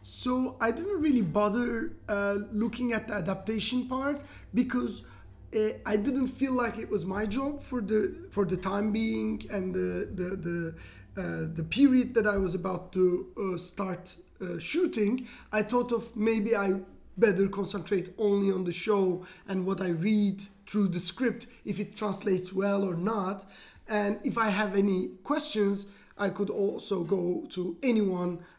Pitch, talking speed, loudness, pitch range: 205 Hz, 165 wpm, -30 LUFS, 185-225 Hz